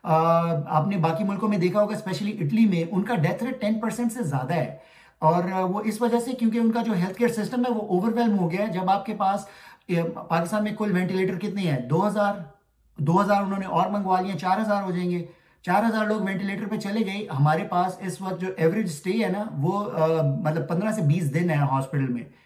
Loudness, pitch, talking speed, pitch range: -25 LUFS, 190 Hz, 220 wpm, 165-210 Hz